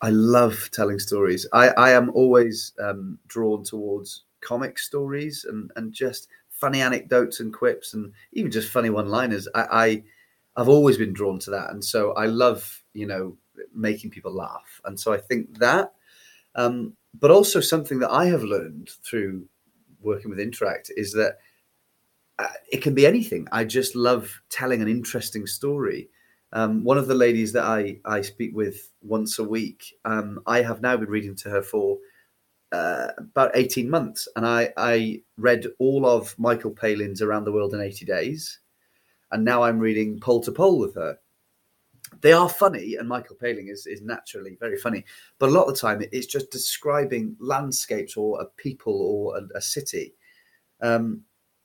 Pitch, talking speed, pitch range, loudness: 120 Hz, 175 wpm, 110-135 Hz, -23 LUFS